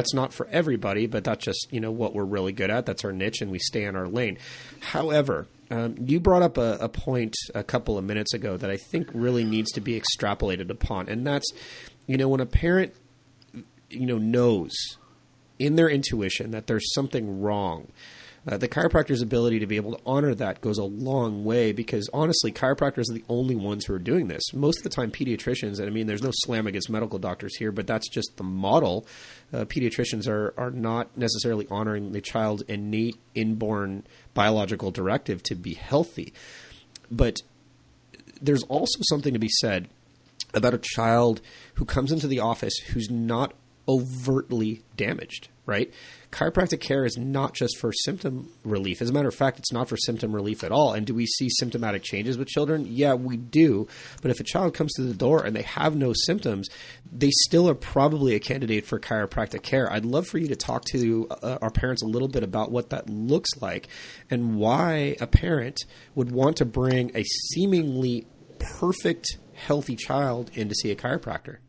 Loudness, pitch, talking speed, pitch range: -26 LUFS, 120 Hz, 195 wpm, 110-135 Hz